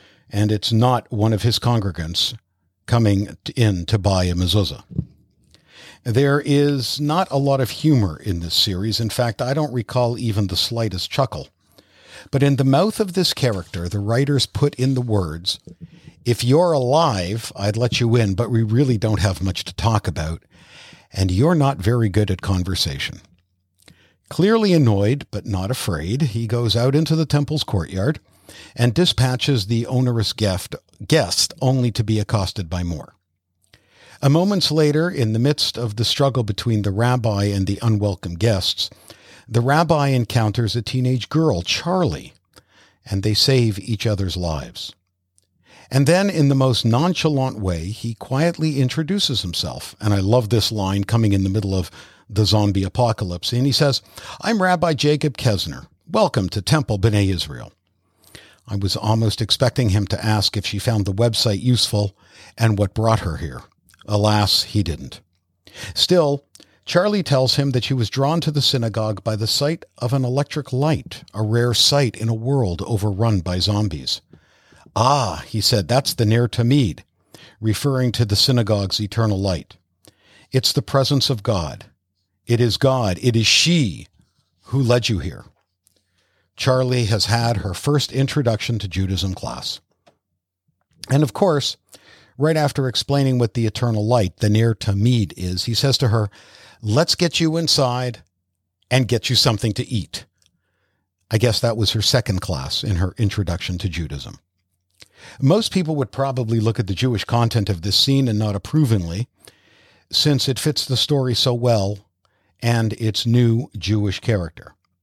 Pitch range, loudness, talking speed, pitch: 100-130 Hz, -19 LUFS, 160 wpm, 115 Hz